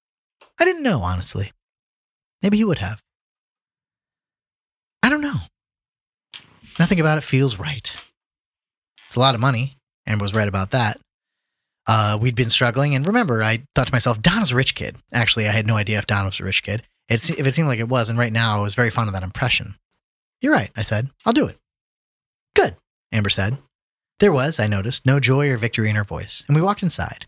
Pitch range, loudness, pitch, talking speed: 105-140 Hz, -20 LUFS, 120 Hz, 205 wpm